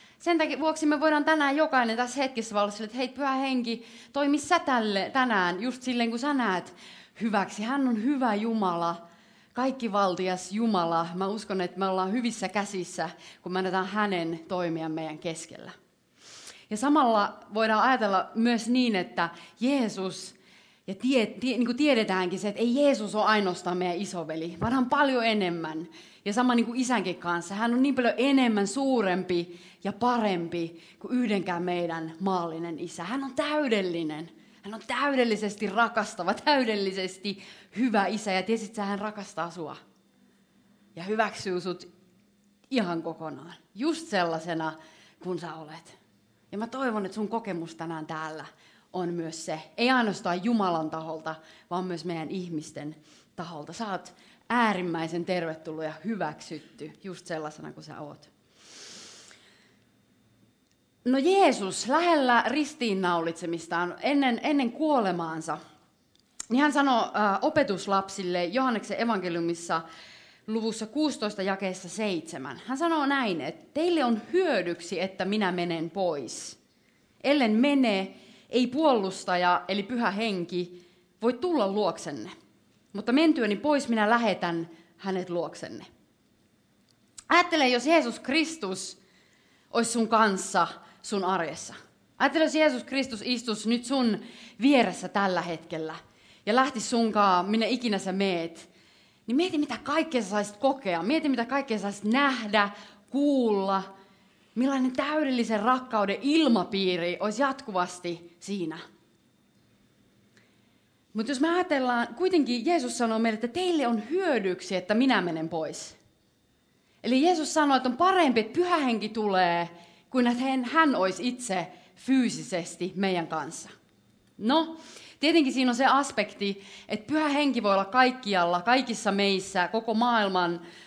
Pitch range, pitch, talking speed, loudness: 180-255 Hz, 210 Hz, 130 wpm, -27 LUFS